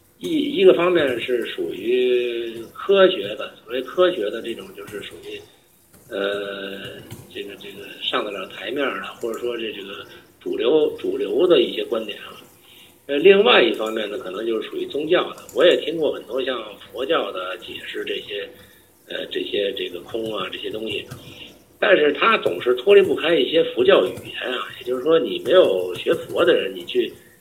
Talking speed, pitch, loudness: 260 characters per minute, 390 Hz, -20 LUFS